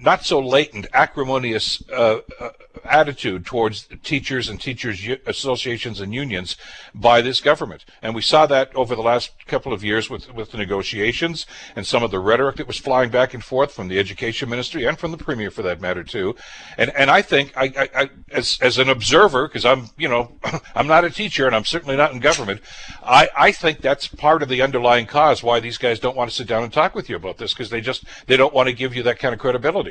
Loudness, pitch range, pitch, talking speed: -19 LUFS, 115-135 Hz, 125 Hz, 235 wpm